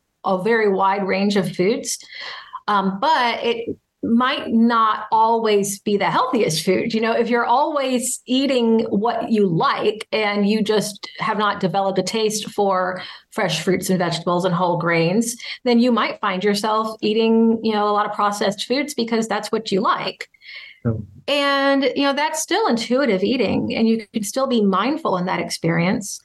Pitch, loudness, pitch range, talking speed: 215 Hz, -19 LUFS, 195-235 Hz, 170 wpm